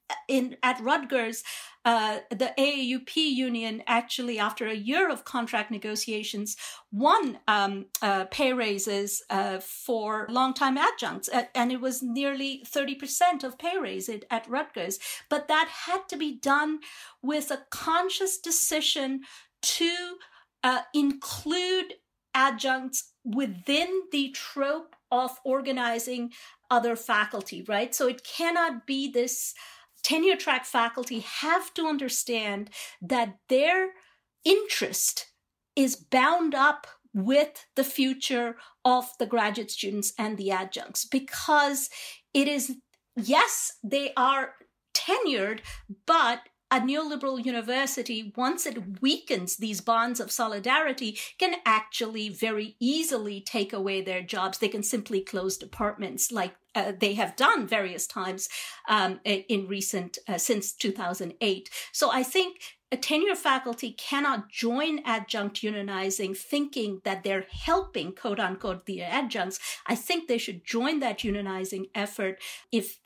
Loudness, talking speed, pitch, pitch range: -28 LUFS, 125 wpm, 250 Hz, 215-280 Hz